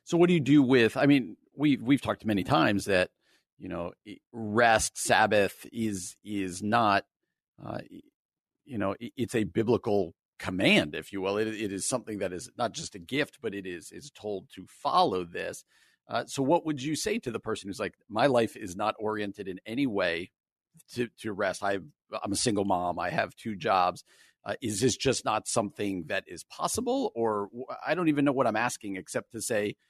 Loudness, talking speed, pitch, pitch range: -29 LUFS, 200 wpm, 115 Hz, 100-140 Hz